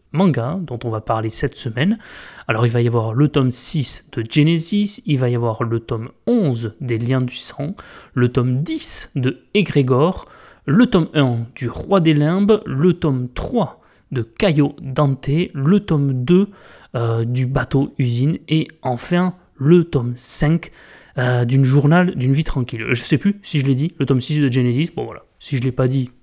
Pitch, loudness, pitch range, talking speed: 140 Hz, -18 LUFS, 125-160 Hz, 190 wpm